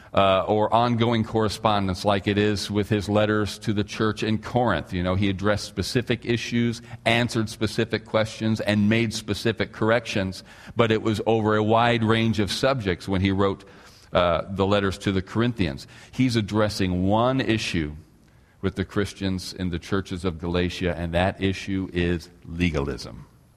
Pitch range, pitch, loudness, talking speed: 95-110 Hz, 105 Hz, -24 LUFS, 160 wpm